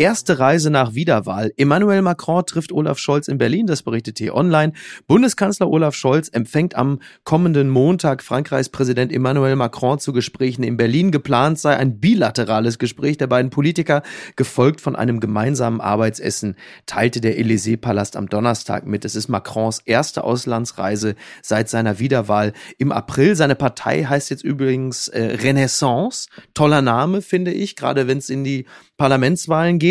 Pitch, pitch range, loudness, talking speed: 135 Hz, 115-155 Hz, -18 LUFS, 150 wpm